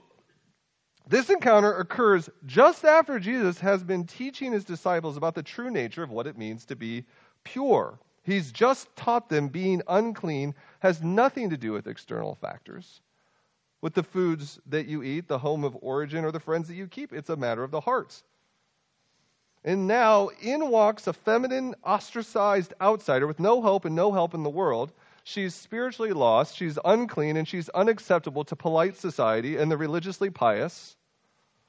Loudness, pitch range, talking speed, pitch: -26 LUFS, 155-215 Hz, 170 wpm, 185 Hz